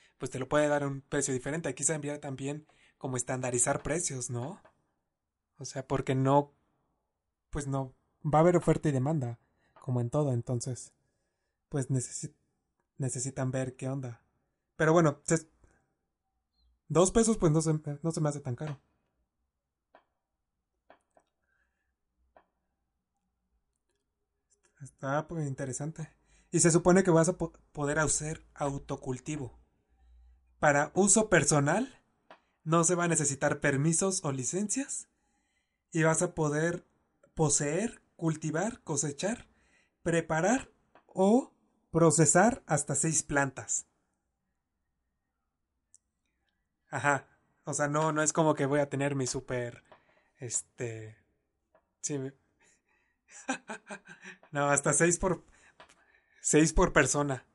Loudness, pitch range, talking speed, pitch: -30 LUFS, 125-160 Hz, 120 wpm, 145 Hz